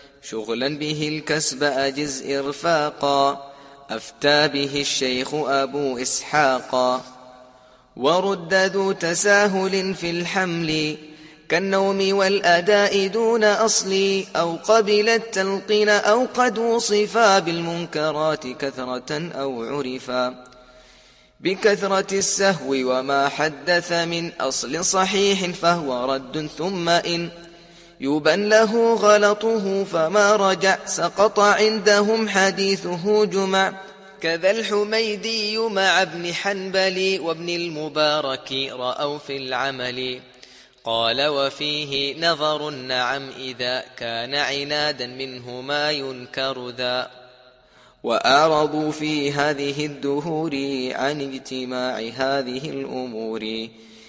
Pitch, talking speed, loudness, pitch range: 155 Hz, 85 wpm, -21 LUFS, 135-195 Hz